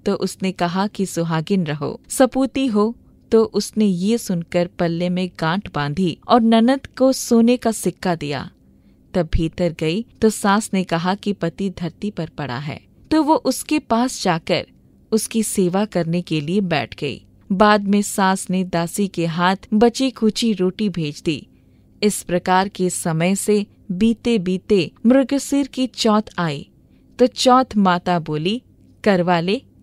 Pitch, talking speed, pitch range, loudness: 195 Hz, 155 wpm, 175-225 Hz, -19 LUFS